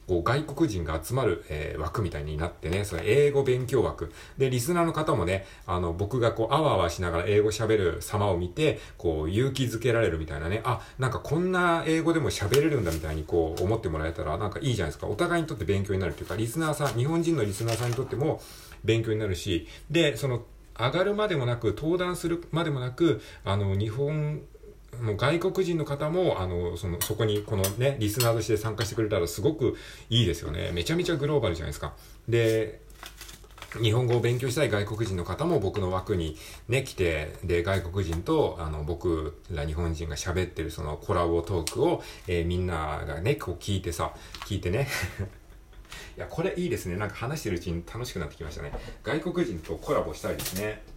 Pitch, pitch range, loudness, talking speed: 110 Hz, 85-135 Hz, -28 LUFS, 410 characters per minute